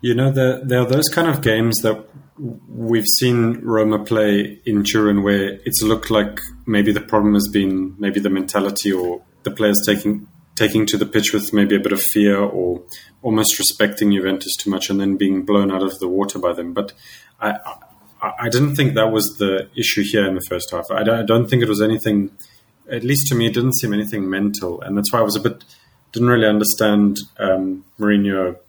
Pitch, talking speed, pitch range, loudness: 105 Hz, 215 wpm, 100-115 Hz, -18 LUFS